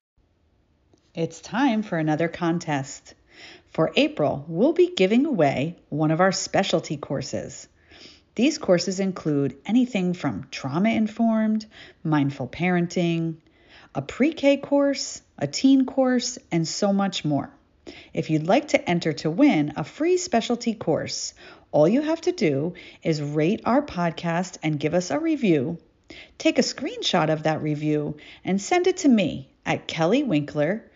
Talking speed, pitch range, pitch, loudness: 145 wpm, 155-250 Hz, 180 Hz, -23 LUFS